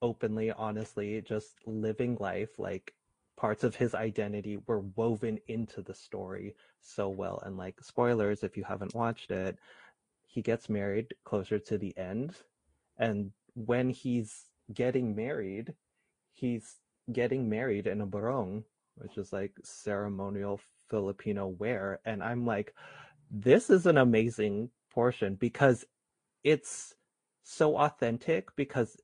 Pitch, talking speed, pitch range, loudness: 110 Hz, 130 wpm, 105-120 Hz, -33 LUFS